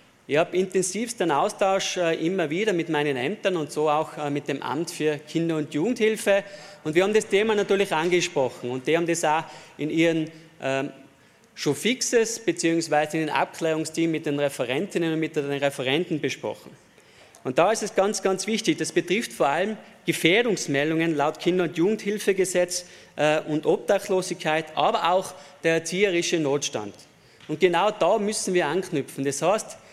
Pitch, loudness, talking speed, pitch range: 165 Hz, -24 LUFS, 160 wpm, 150-195 Hz